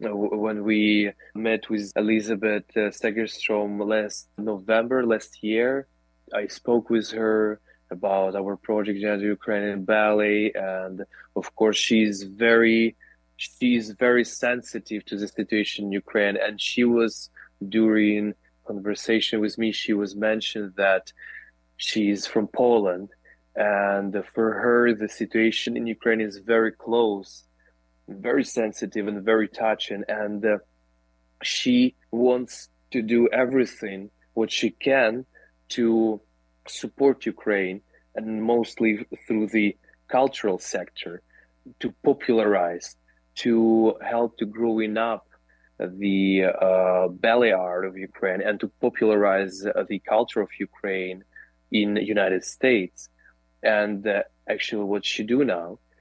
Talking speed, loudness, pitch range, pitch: 120 wpm, -24 LUFS, 100-115 Hz, 105 Hz